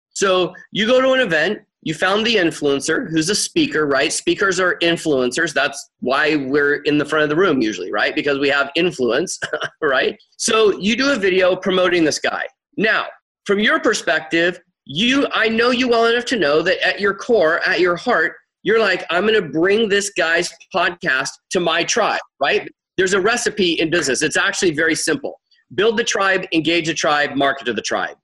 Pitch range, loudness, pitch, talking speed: 160-215 Hz, -17 LUFS, 180 Hz, 195 wpm